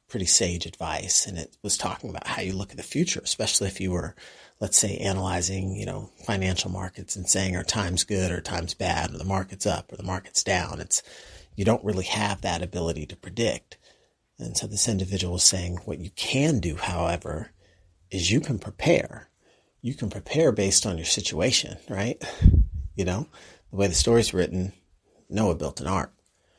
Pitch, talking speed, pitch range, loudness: 95 Hz, 190 wpm, 90-100 Hz, -25 LUFS